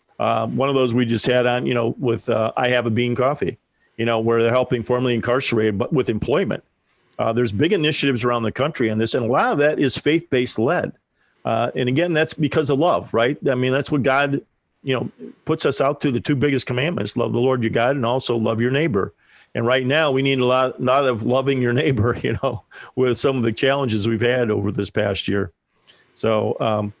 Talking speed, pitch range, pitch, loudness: 235 wpm, 115-135 Hz, 125 Hz, -20 LUFS